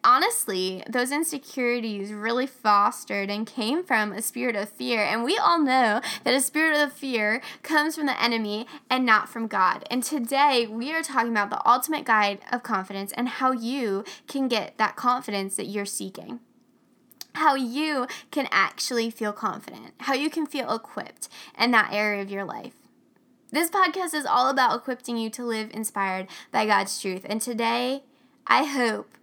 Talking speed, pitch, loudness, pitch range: 170 wpm, 240 Hz, -25 LUFS, 210-275 Hz